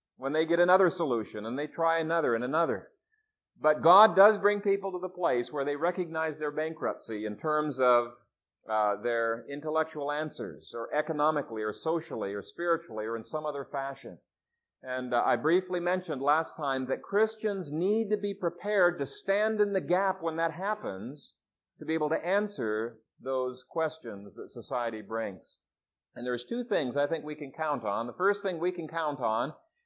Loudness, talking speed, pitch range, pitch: -30 LUFS, 180 wpm, 130-185 Hz, 160 Hz